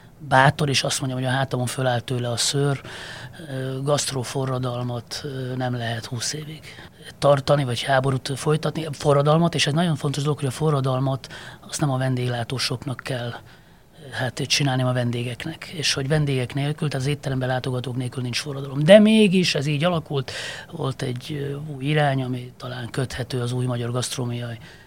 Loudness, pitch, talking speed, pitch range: -23 LUFS, 135 Hz, 155 wpm, 125-145 Hz